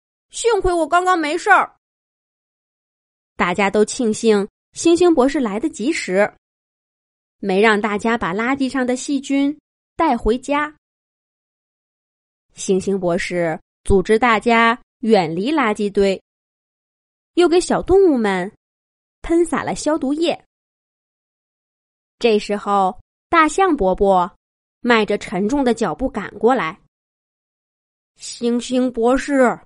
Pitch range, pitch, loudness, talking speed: 205-295 Hz, 235 Hz, -18 LUFS, 165 characters per minute